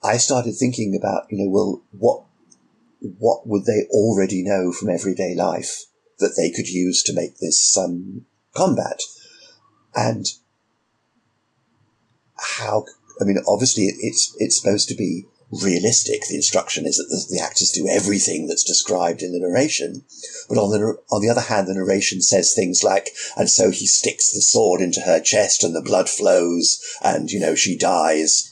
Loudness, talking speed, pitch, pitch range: -18 LUFS, 170 wpm, 110 Hz, 95-120 Hz